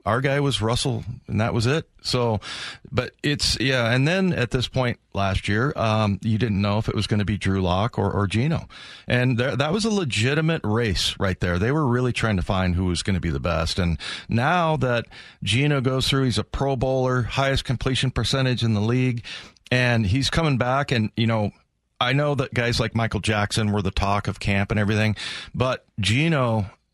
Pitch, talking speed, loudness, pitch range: 115 Hz, 210 wpm, -23 LUFS, 105-130 Hz